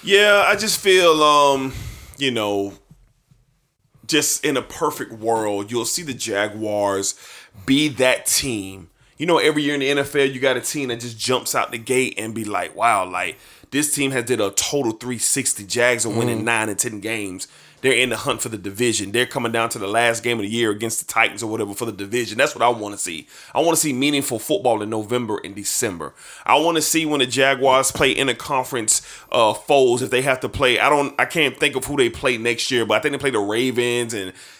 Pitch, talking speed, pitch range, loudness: 120 Hz, 230 wpm, 110-140 Hz, -19 LUFS